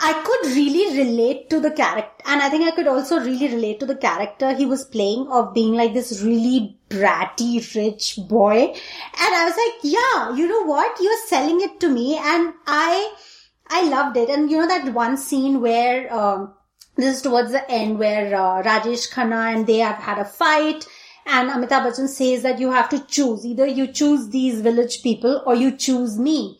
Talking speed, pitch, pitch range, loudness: 200 wpm, 260 Hz, 235-300 Hz, -19 LUFS